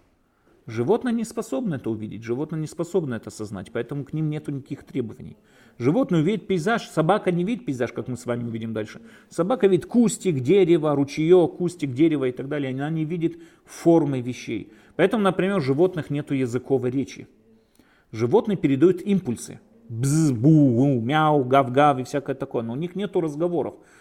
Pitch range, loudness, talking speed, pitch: 130-180 Hz, -23 LUFS, 165 wpm, 150 Hz